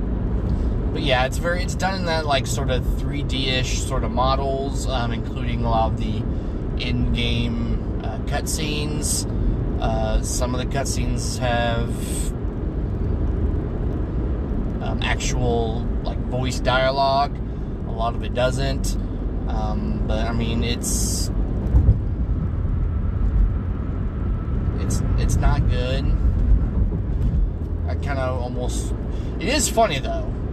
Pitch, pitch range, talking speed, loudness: 100 Hz, 85-115 Hz, 110 wpm, -23 LUFS